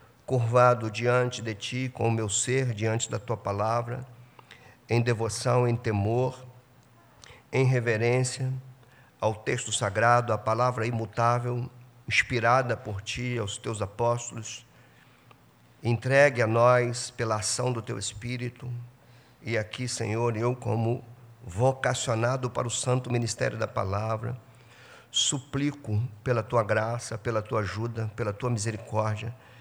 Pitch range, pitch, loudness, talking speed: 115-125 Hz, 120 Hz, -27 LUFS, 120 wpm